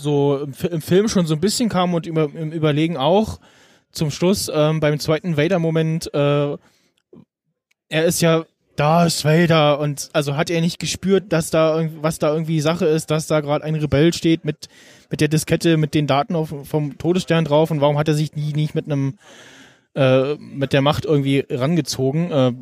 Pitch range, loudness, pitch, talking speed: 145-165 Hz, -19 LUFS, 155 Hz, 195 wpm